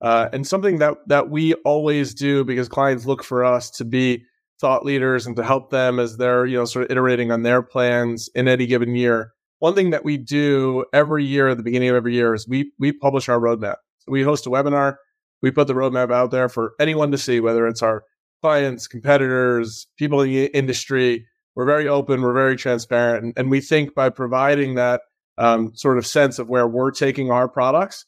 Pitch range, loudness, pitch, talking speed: 120-140 Hz, -19 LUFS, 130 Hz, 215 wpm